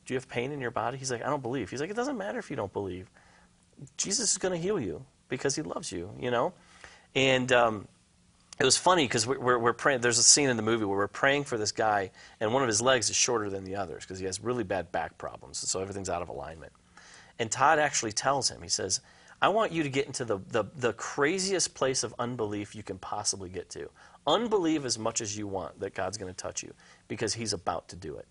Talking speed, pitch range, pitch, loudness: 255 wpm, 105-145 Hz, 120 Hz, -29 LUFS